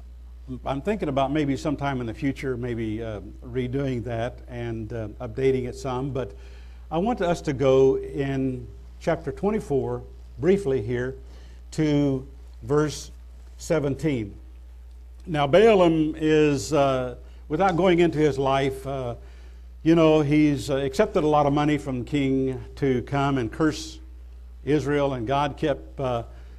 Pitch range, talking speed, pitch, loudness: 105-145 Hz, 135 wpm, 135 Hz, -24 LUFS